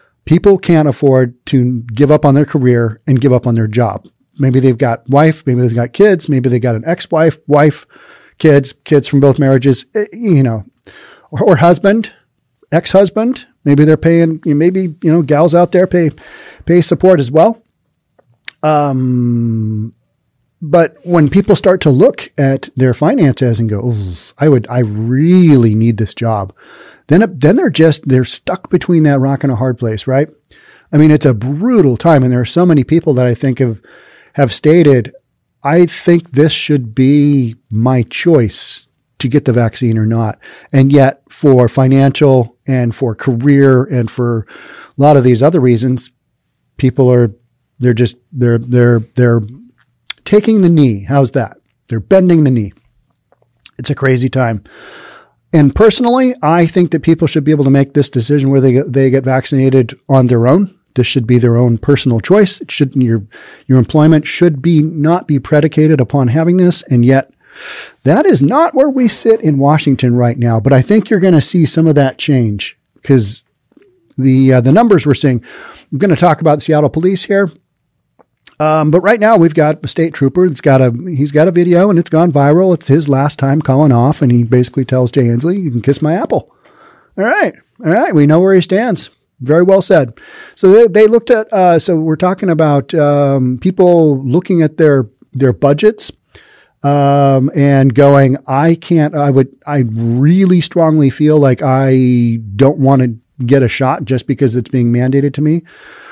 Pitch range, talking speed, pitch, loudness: 125-165 Hz, 185 wpm, 140 Hz, -11 LUFS